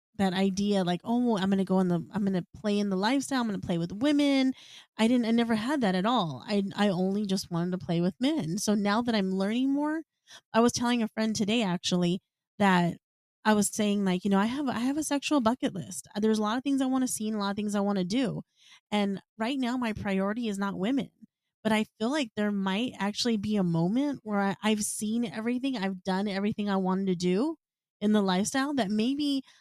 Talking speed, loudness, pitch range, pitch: 245 wpm, -28 LUFS, 195-240 Hz, 210 Hz